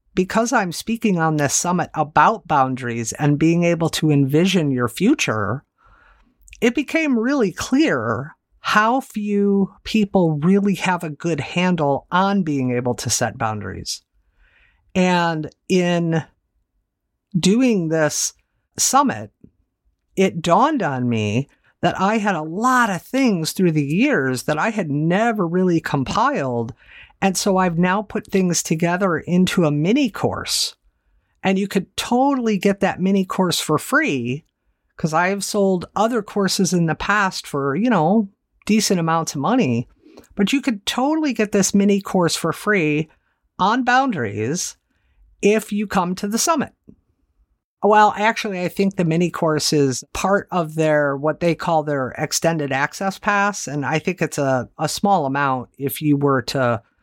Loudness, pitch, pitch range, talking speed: -19 LUFS, 175 Hz, 145-200 Hz, 150 wpm